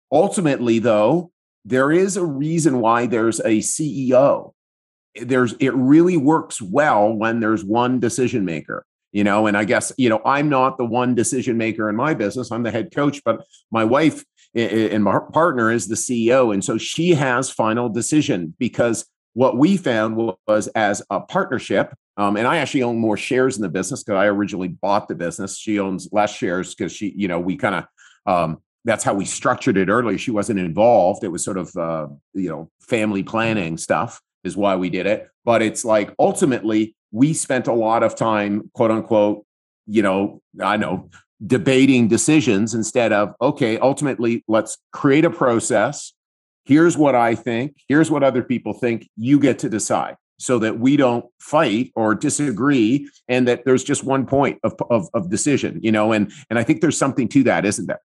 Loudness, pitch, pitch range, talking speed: -19 LUFS, 115 Hz, 105-135 Hz, 190 wpm